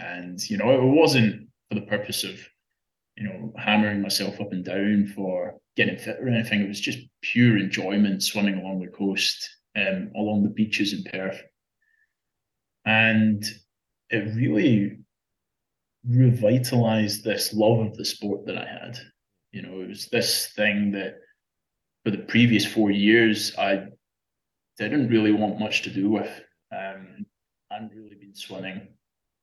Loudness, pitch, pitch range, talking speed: -23 LUFS, 105 Hz, 100-115 Hz, 150 wpm